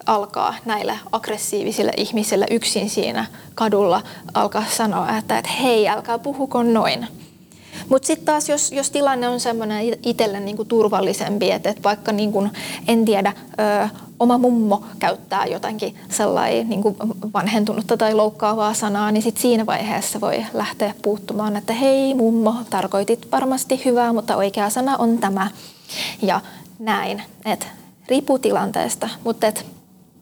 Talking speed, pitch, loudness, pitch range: 135 wpm, 220 Hz, -20 LUFS, 210-240 Hz